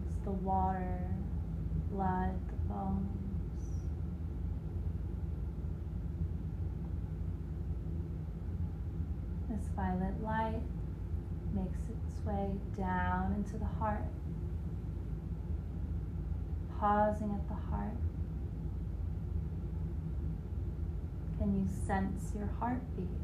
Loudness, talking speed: -38 LUFS, 60 wpm